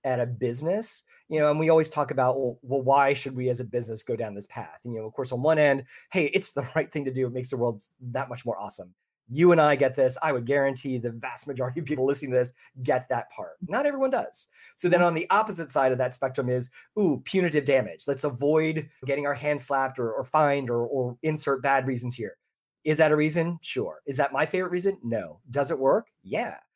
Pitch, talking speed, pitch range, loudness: 140 Hz, 245 wpm, 125-155 Hz, -26 LUFS